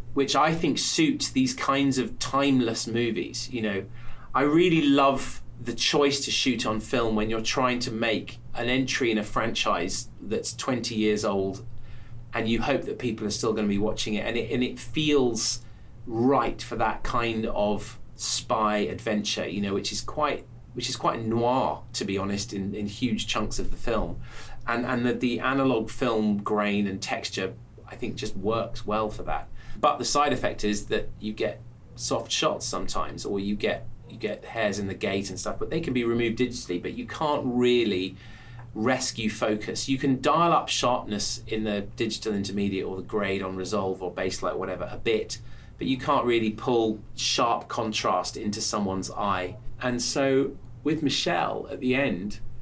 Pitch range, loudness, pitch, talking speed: 105-125 Hz, -26 LUFS, 115 Hz, 185 wpm